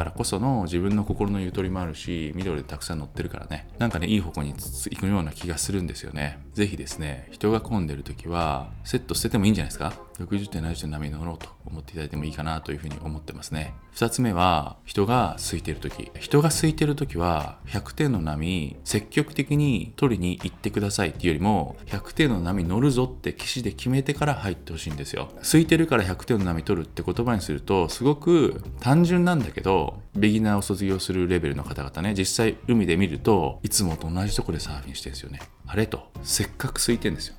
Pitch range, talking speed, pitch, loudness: 75-110 Hz, 440 characters per minute, 90 Hz, -25 LUFS